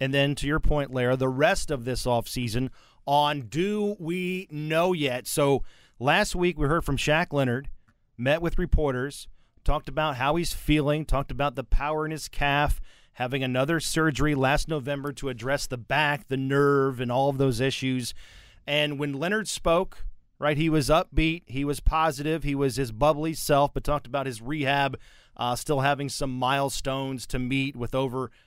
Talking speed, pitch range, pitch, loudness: 180 wpm, 130-150 Hz, 140 Hz, -26 LUFS